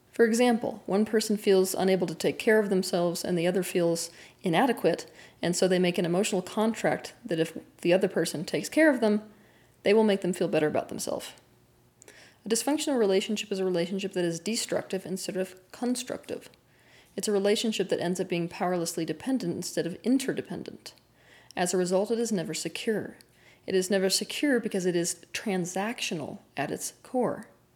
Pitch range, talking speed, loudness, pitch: 175-215 Hz, 175 wpm, -28 LUFS, 190 Hz